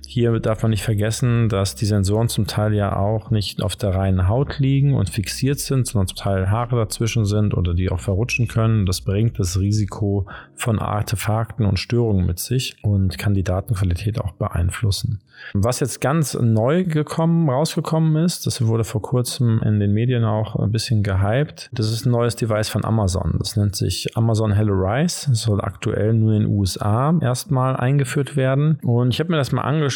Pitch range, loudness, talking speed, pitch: 100-130 Hz, -20 LUFS, 190 wpm, 110 Hz